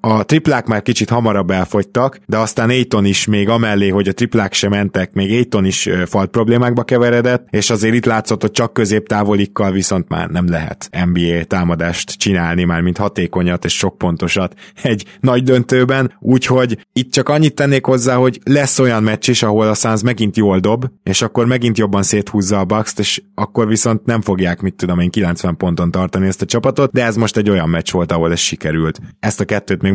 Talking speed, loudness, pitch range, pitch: 200 wpm, -15 LUFS, 95-120 Hz, 105 Hz